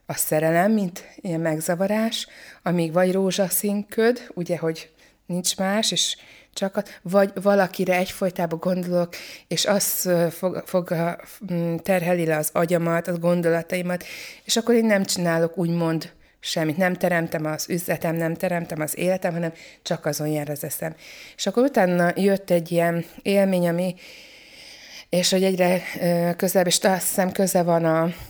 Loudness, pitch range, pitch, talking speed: -23 LUFS, 170-195 Hz, 180 Hz, 140 wpm